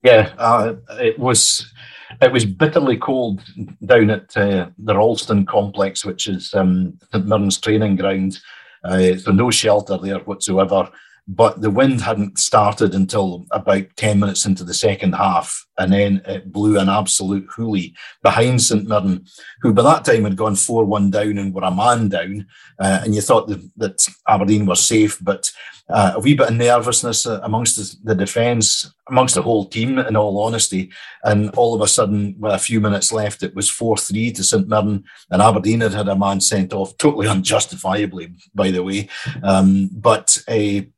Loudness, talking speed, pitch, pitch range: -17 LUFS, 180 wpm, 100 Hz, 95-110 Hz